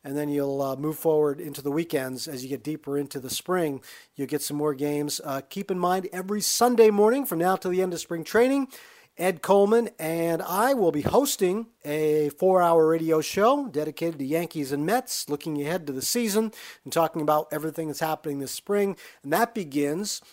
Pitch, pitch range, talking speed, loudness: 160 Hz, 145-195 Hz, 205 wpm, -25 LUFS